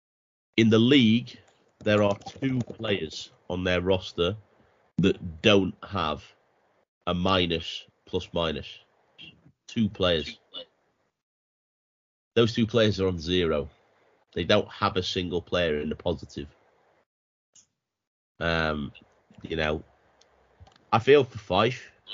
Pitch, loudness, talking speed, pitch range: 95 Hz, -26 LUFS, 110 wpm, 85-110 Hz